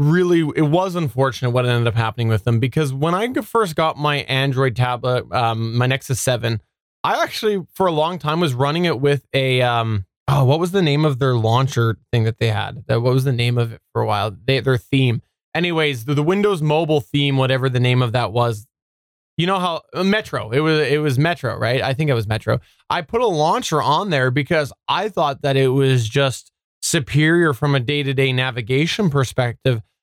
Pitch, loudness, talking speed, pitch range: 135 Hz, -19 LUFS, 210 wpm, 120-155 Hz